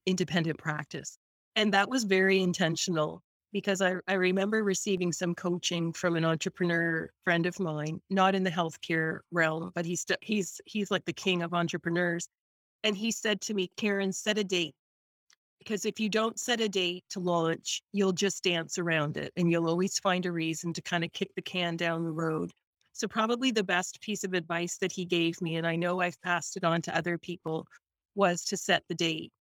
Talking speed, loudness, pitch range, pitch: 200 wpm, -30 LUFS, 170-195 Hz, 180 Hz